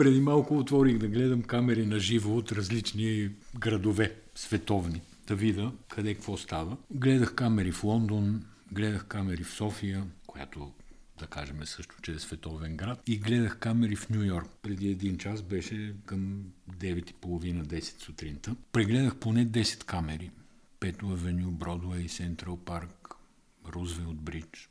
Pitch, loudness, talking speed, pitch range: 100 Hz, -31 LUFS, 140 wpm, 85-110 Hz